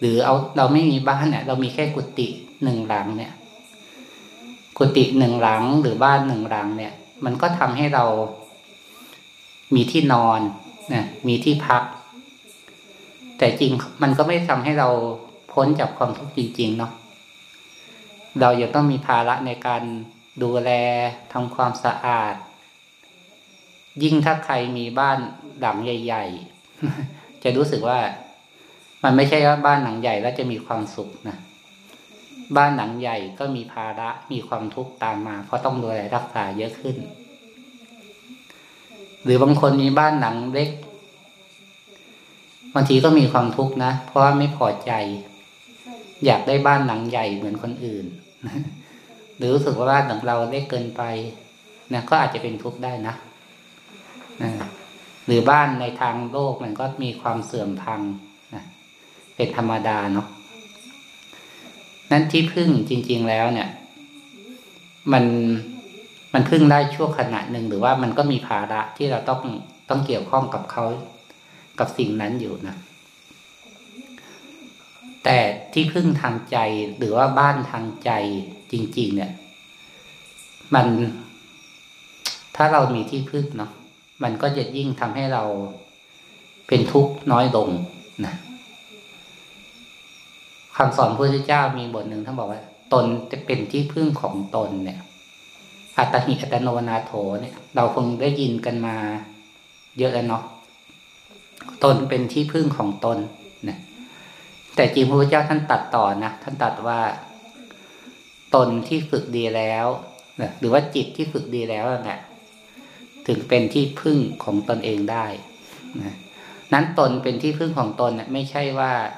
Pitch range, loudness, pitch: 115-150 Hz, -21 LUFS, 130 Hz